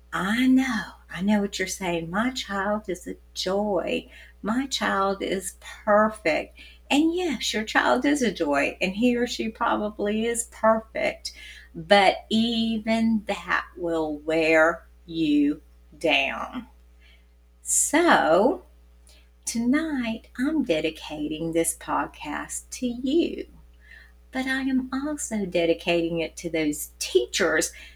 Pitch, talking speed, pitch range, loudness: 200 Hz, 115 wpm, 155-235 Hz, -24 LUFS